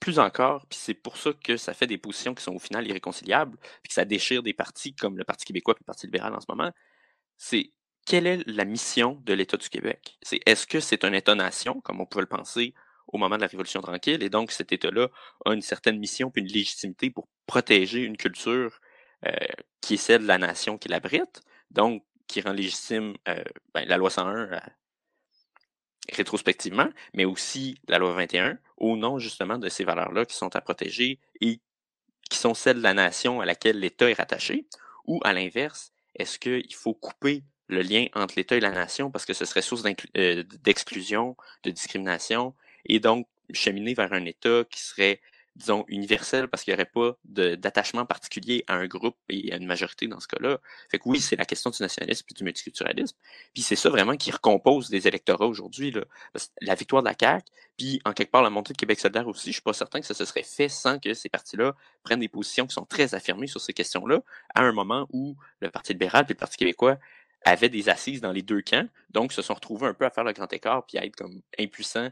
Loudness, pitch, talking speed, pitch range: -26 LUFS, 115 Hz, 220 wpm, 100-130 Hz